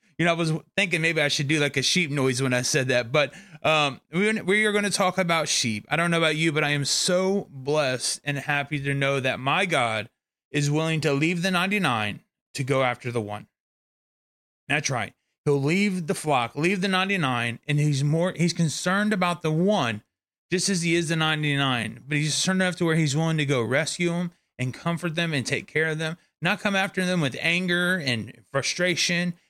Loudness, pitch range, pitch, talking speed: -24 LUFS, 140-175 Hz, 155 Hz, 220 wpm